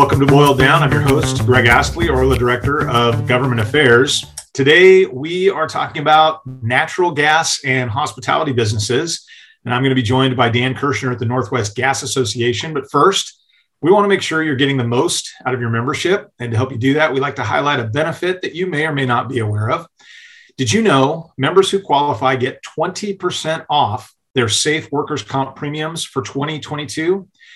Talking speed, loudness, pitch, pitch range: 195 wpm, -15 LUFS, 140 Hz, 125-160 Hz